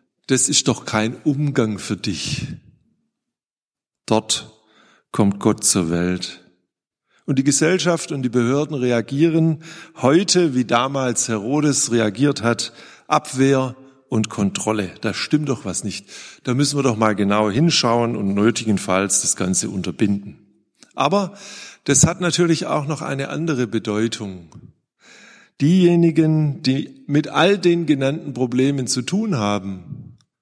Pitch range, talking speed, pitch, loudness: 110-150 Hz, 125 wpm, 130 Hz, -19 LUFS